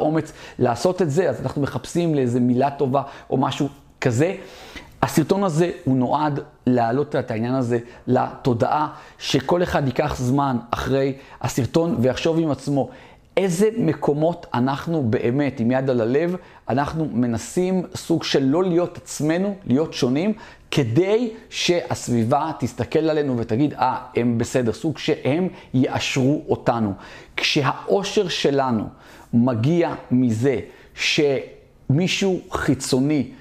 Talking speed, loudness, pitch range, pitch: 120 wpm, -21 LUFS, 125-165 Hz, 140 Hz